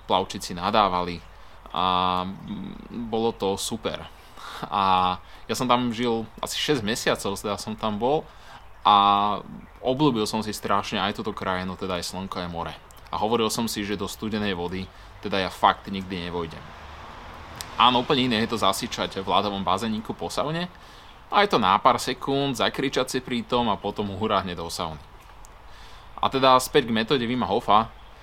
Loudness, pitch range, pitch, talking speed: -24 LUFS, 90-115 Hz, 100 Hz, 160 wpm